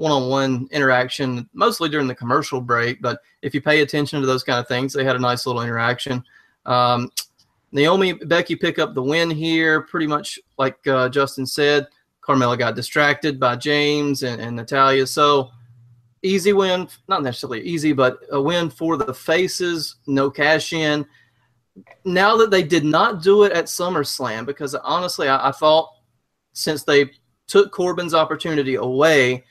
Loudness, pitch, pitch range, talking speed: -19 LUFS, 145 Hz, 125-160 Hz, 165 wpm